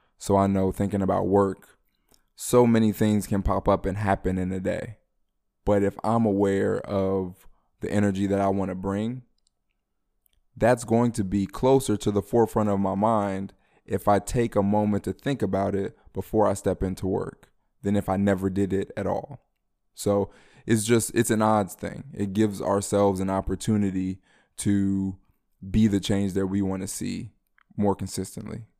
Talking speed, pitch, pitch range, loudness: 175 wpm, 100 Hz, 95-105 Hz, -25 LUFS